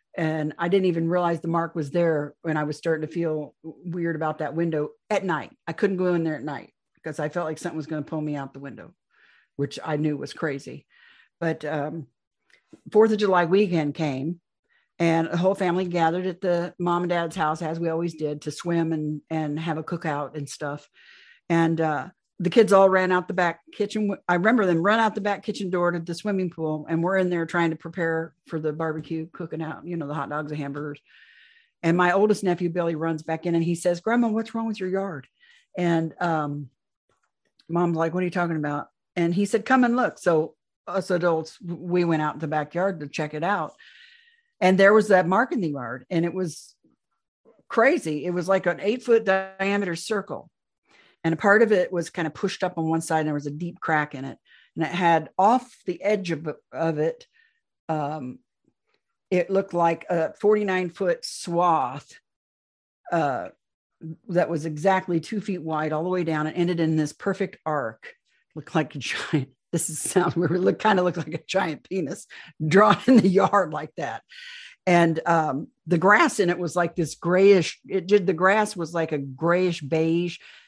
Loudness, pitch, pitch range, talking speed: -24 LUFS, 170 Hz, 155-190 Hz, 210 wpm